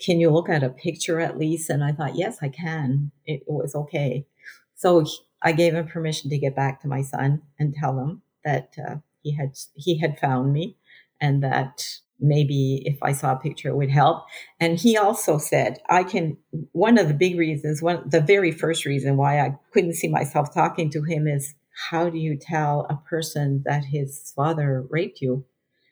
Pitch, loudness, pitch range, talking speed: 150 Hz, -23 LUFS, 140-165 Hz, 200 wpm